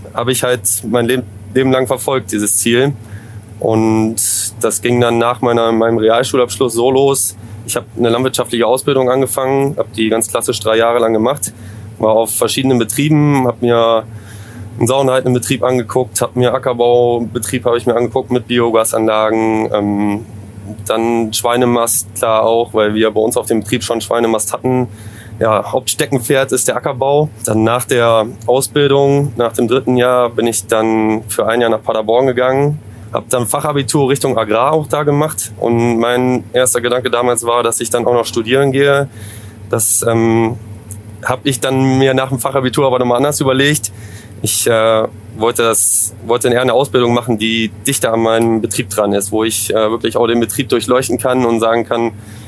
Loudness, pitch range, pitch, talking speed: -13 LUFS, 110-130 Hz, 120 Hz, 175 wpm